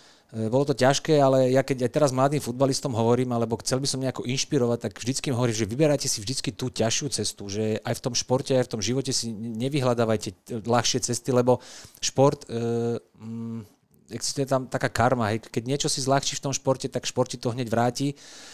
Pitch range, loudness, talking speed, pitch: 115-135 Hz, -25 LUFS, 195 wpm, 125 Hz